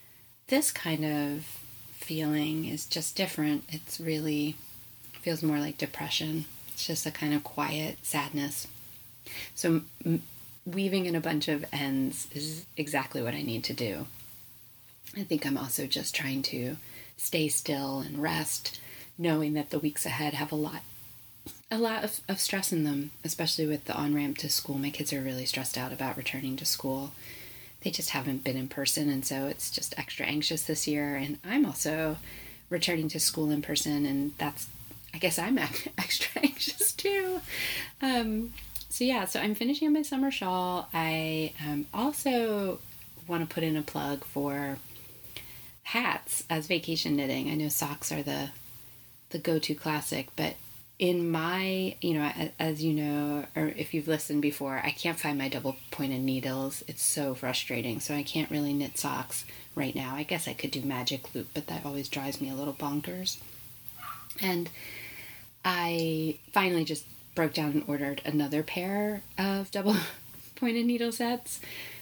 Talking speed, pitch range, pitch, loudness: 170 wpm, 135-165 Hz, 150 Hz, -31 LUFS